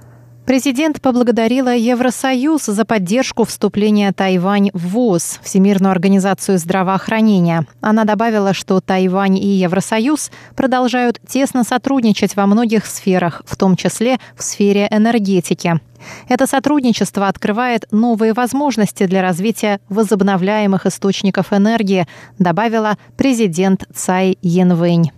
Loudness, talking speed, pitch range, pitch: -15 LUFS, 105 wpm, 190-235 Hz, 205 Hz